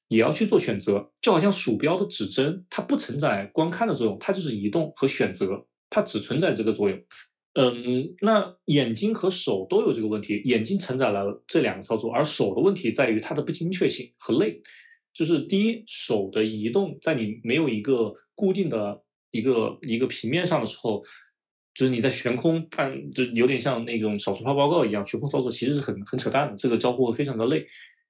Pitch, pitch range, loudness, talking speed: 135 Hz, 110-185 Hz, -25 LUFS, 305 characters per minute